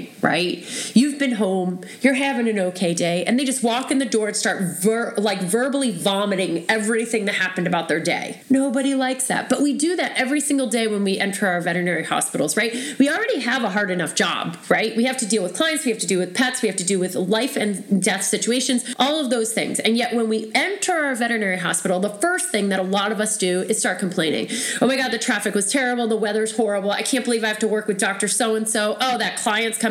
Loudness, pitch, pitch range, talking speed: -20 LUFS, 220 Hz, 200-255 Hz, 250 wpm